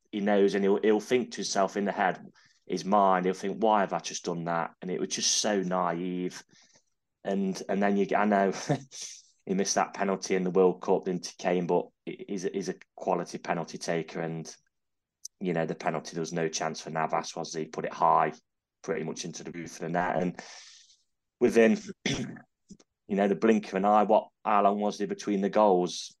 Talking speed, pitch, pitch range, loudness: 215 wpm, 100 Hz, 90-105 Hz, -28 LUFS